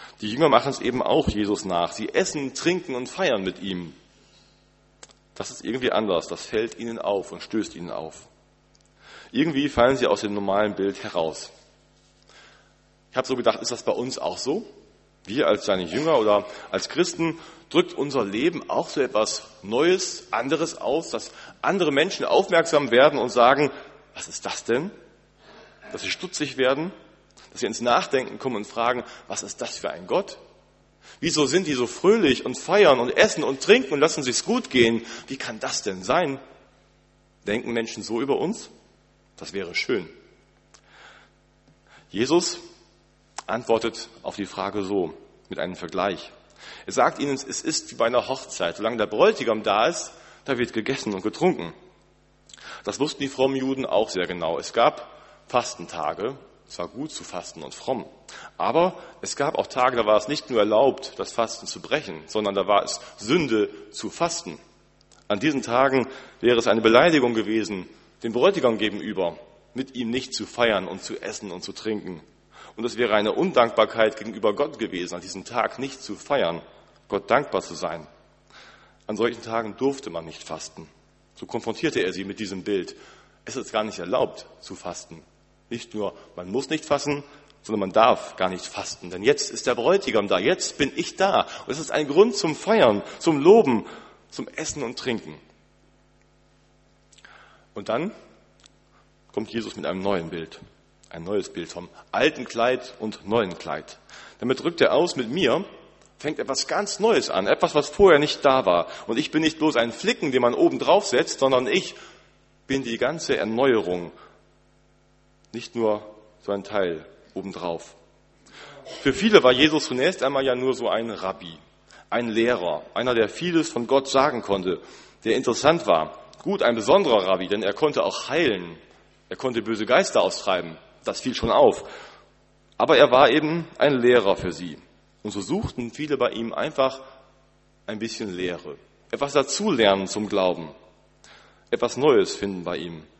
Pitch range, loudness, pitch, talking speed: 105-145 Hz, -23 LUFS, 120 Hz, 170 wpm